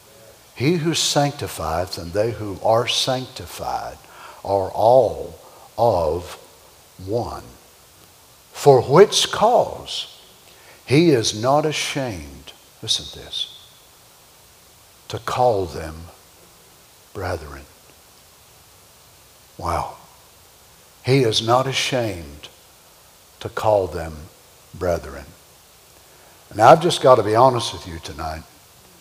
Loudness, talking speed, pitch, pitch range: -19 LUFS, 95 wpm, 100 Hz, 85-125 Hz